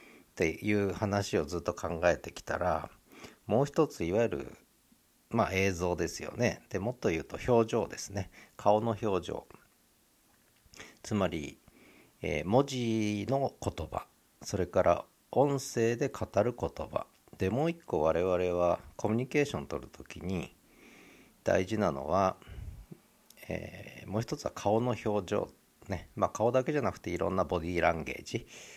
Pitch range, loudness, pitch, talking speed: 90-120 Hz, -32 LUFS, 105 Hz, 270 characters per minute